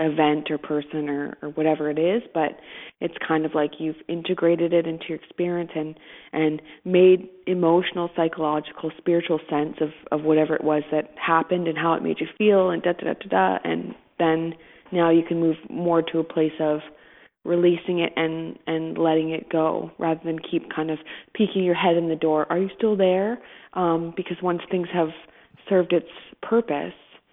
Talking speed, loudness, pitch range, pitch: 190 wpm, -23 LUFS, 155-175 Hz, 165 Hz